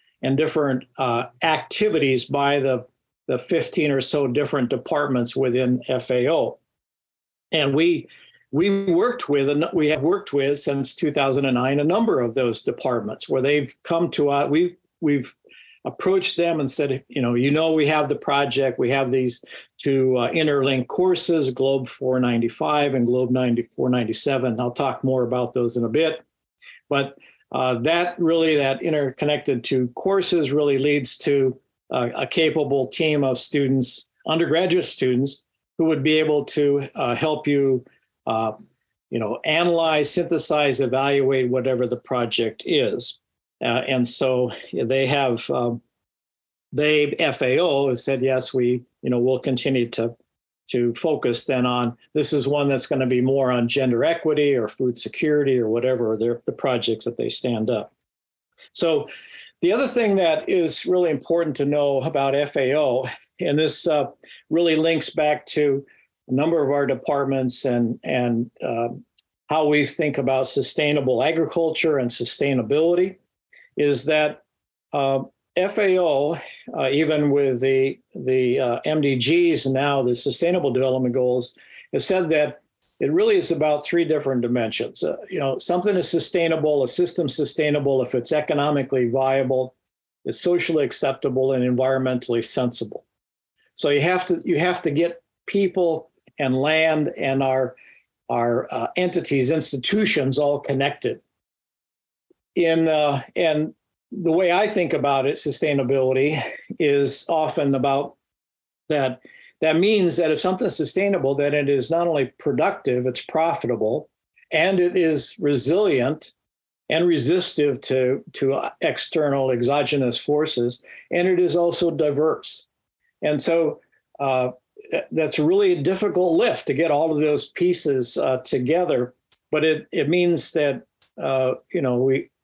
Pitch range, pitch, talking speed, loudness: 130-160 Hz, 140 Hz, 145 wpm, -21 LUFS